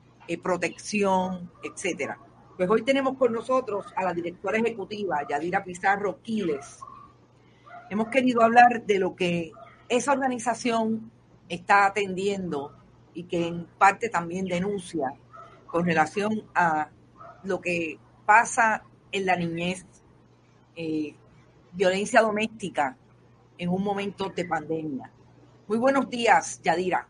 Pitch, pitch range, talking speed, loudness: 195 Hz, 170-220 Hz, 115 wpm, -26 LUFS